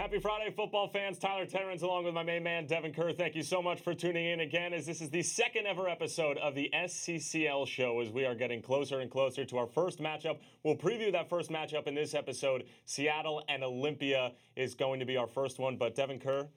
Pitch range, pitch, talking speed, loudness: 135-175 Hz, 155 Hz, 230 wpm, -35 LUFS